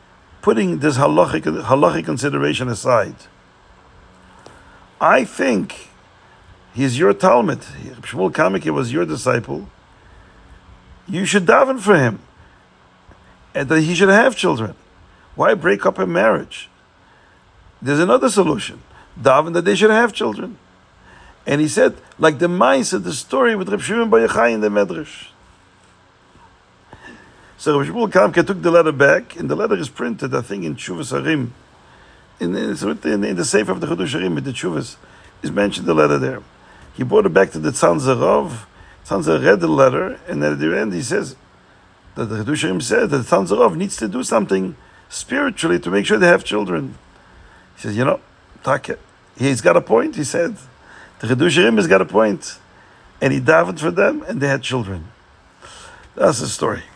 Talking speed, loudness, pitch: 160 wpm, -17 LUFS, 105 Hz